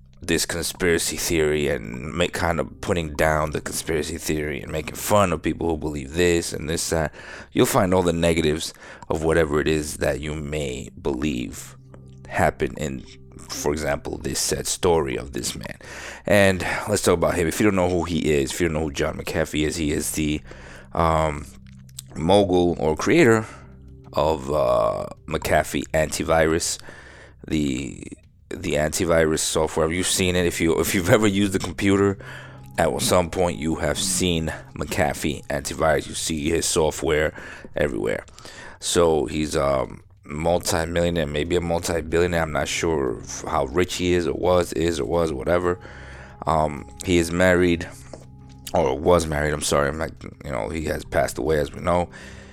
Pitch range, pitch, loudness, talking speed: 75-90 Hz, 80 Hz, -22 LUFS, 165 wpm